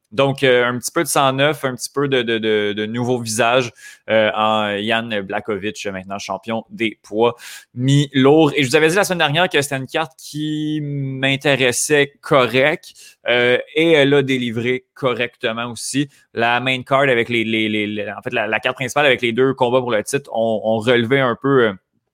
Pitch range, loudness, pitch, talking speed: 115-140 Hz, -17 LUFS, 125 Hz, 200 wpm